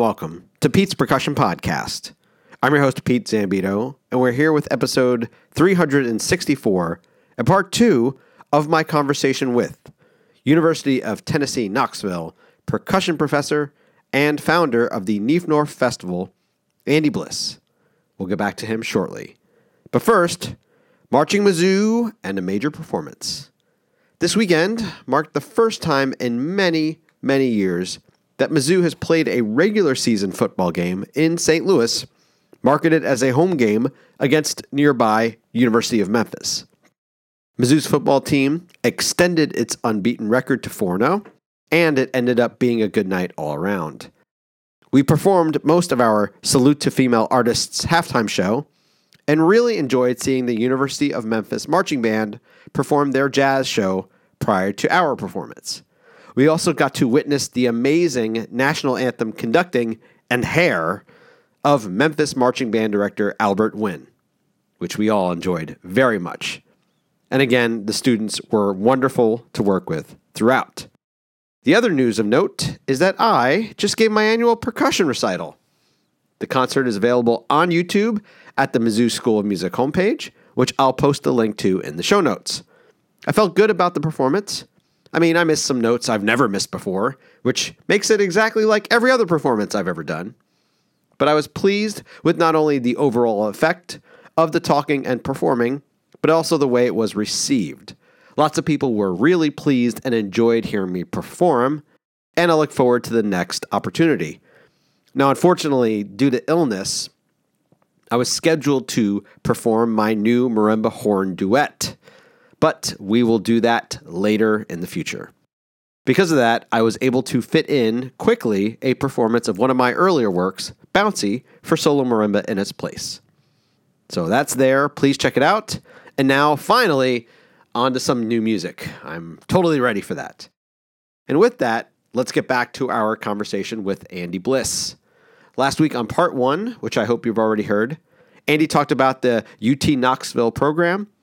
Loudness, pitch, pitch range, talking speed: -19 LUFS, 130 Hz, 115-155 Hz, 160 wpm